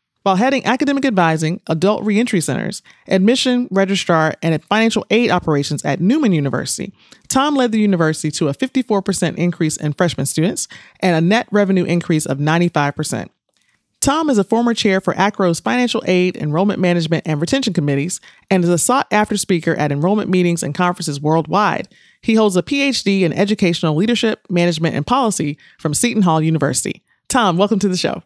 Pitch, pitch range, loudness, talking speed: 180 Hz, 160-215 Hz, -16 LUFS, 170 wpm